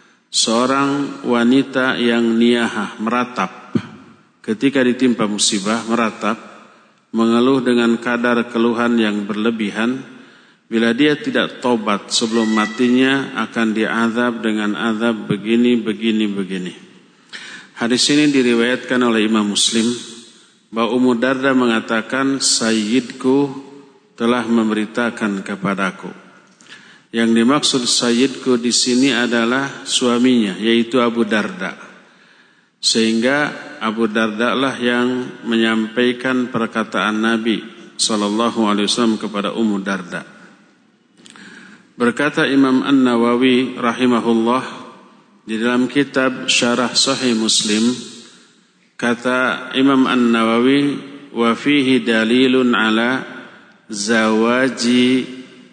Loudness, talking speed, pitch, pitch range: -16 LUFS, 90 wpm, 120 Hz, 115-130 Hz